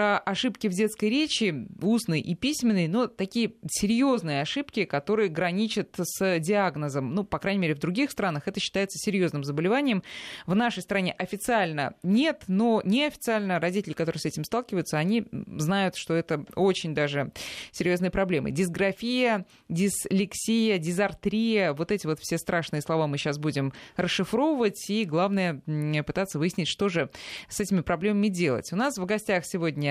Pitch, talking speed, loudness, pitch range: 190 Hz, 150 wpm, -27 LUFS, 165-215 Hz